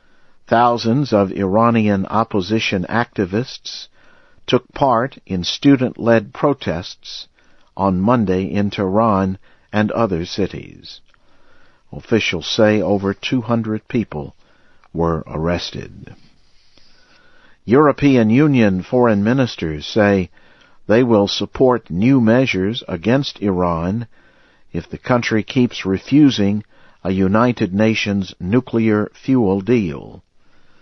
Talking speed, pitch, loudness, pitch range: 90 wpm, 105 Hz, -17 LUFS, 95-120 Hz